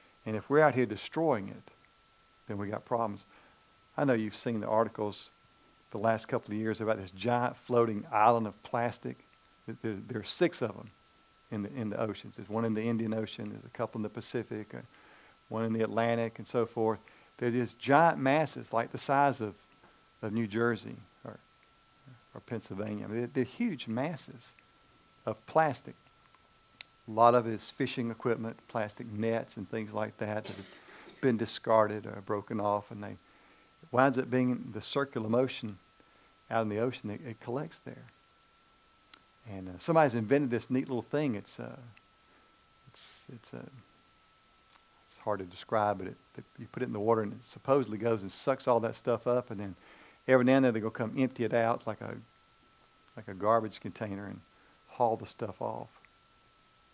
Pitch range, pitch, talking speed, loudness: 105-125 Hz, 115 Hz, 185 wpm, -32 LUFS